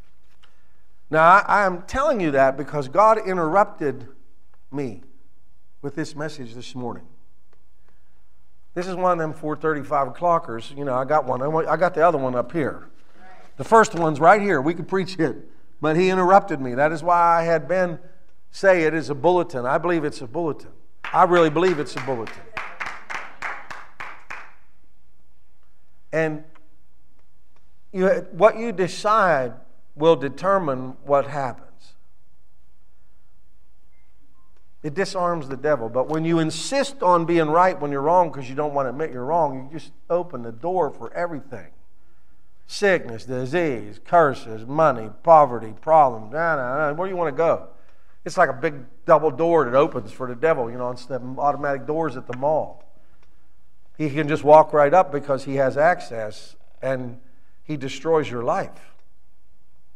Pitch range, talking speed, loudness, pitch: 115-170 Hz, 160 wpm, -21 LUFS, 145 Hz